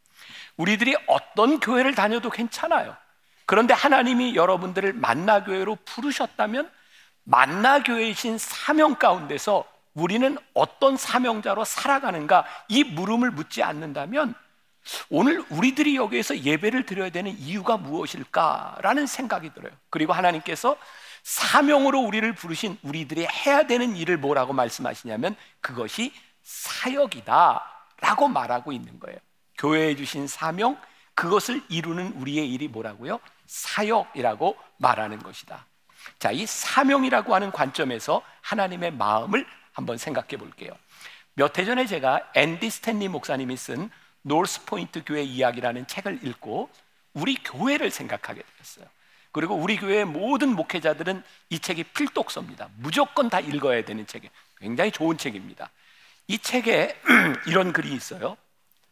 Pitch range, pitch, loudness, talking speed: 165-265 Hz, 215 Hz, -24 LUFS, 330 characters per minute